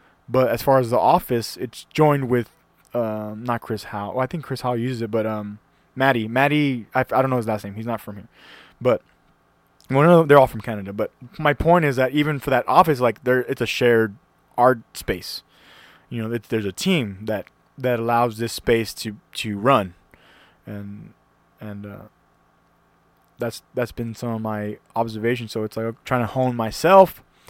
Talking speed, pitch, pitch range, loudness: 195 wpm, 115 Hz, 110-130 Hz, -21 LUFS